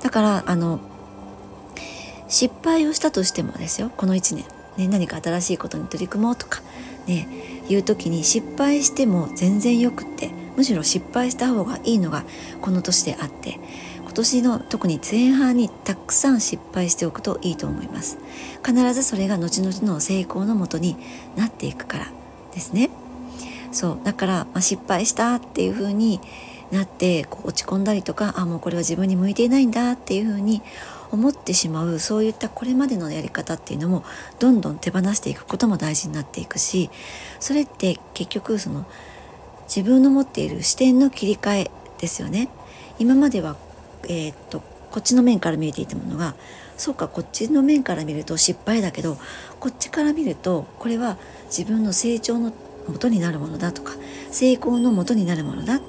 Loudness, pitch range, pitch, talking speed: -21 LUFS, 175-245 Hz, 205 Hz, 325 characters per minute